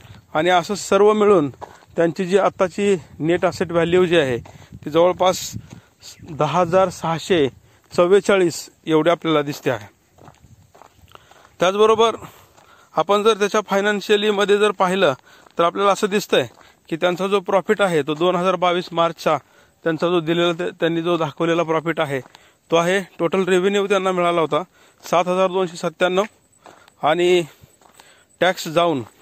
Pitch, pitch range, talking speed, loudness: 175 Hz, 160-190 Hz, 140 wpm, -19 LUFS